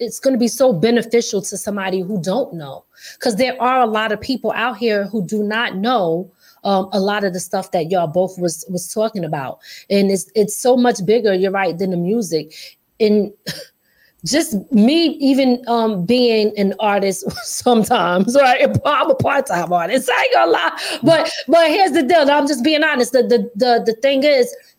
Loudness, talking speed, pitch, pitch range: -16 LUFS, 200 wpm, 220 Hz, 195-255 Hz